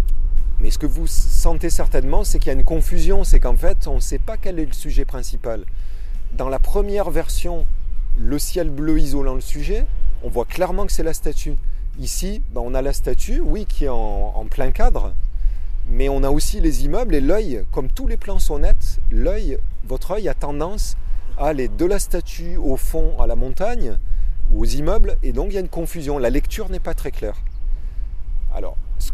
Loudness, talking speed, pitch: -24 LUFS, 205 wpm, 135 Hz